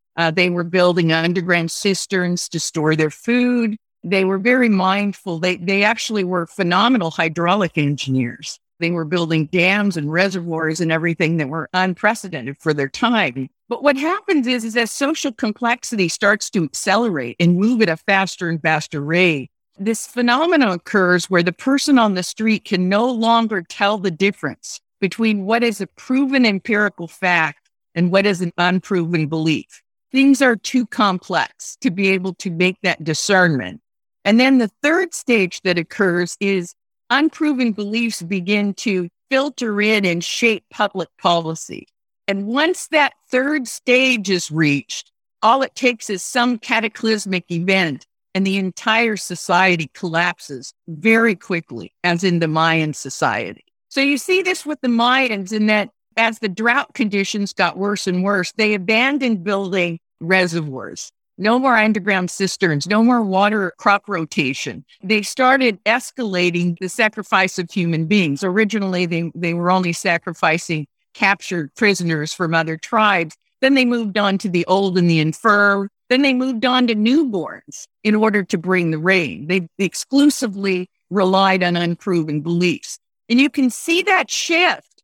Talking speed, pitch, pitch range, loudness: 155 wpm, 195 Hz, 175-230 Hz, -18 LUFS